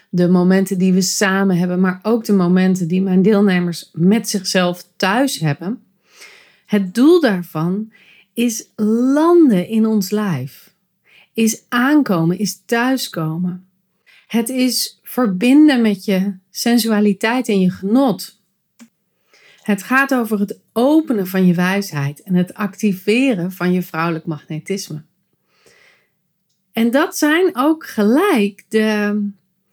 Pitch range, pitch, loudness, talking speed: 185-235 Hz, 200 Hz, -16 LUFS, 120 wpm